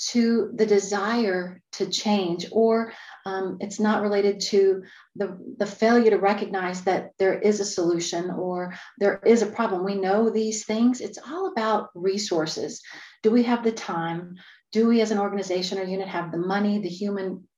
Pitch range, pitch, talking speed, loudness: 185-220 Hz, 200 Hz, 175 wpm, -24 LUFS